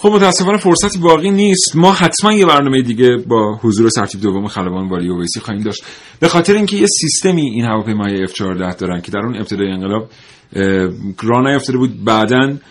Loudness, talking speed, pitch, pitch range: -13 LUFS, 185 wpm, 115 Hz, 100-165 Hz